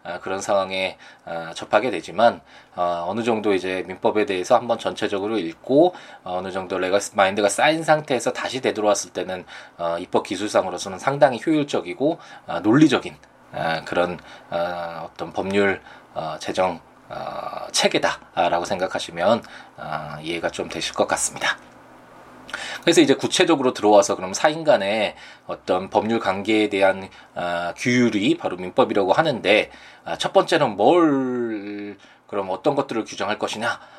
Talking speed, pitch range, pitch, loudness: 295 characters per minute, 90-125 Hz, 100 Hz, -21 LUFS